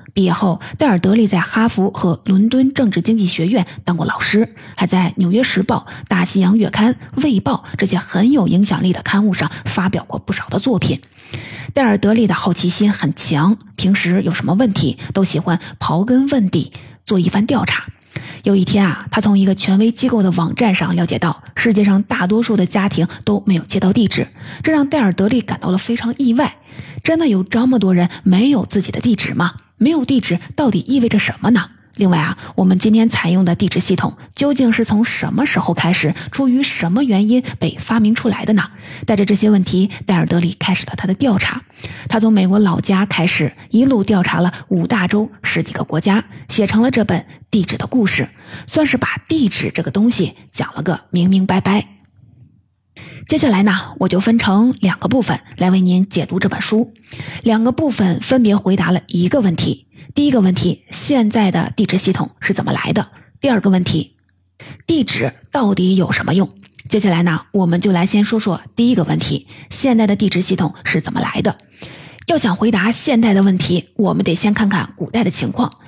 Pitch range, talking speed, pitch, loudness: 175-225 Hz, 295 characters per minute, 195 Hz, -15 LUFS